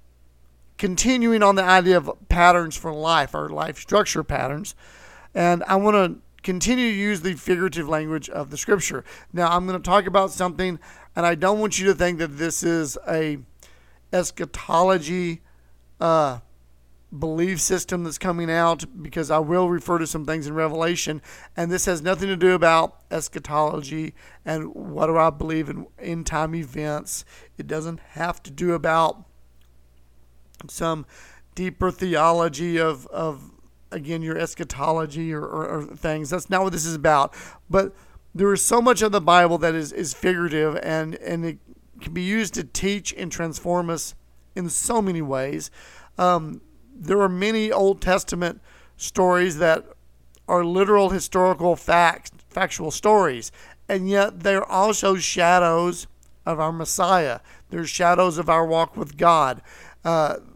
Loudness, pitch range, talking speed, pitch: -22 LUFS, 155-185 Hz, 155 wpm, 170 Hz